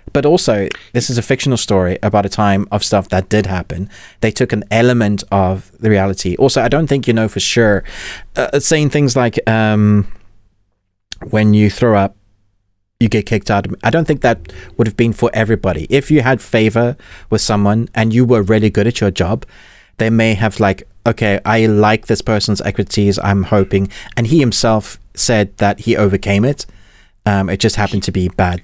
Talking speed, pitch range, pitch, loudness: 195 wpm, 100-115 Hz, 105 Hz, -14 LUFS